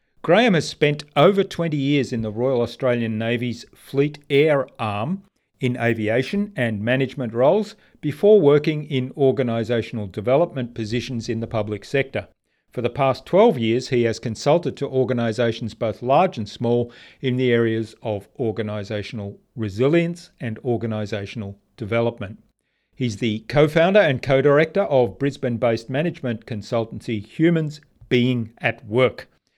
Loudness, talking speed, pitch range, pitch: -21 LUFS, 140 wpm, 115-140 Hz, 120 Hz